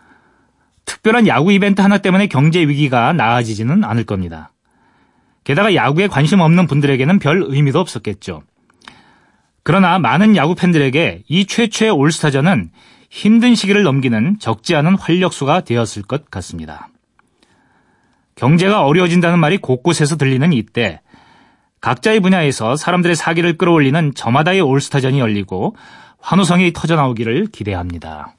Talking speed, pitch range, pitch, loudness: 340 characters per minute, 130-190 Hz, 160 Hz, -14 LUFS